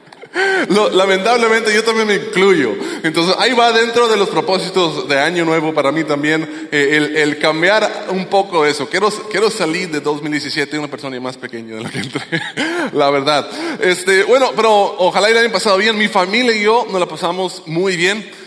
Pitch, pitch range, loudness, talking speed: 185 Hz, 150-215 Hz, -14 LUFS, 185 wpm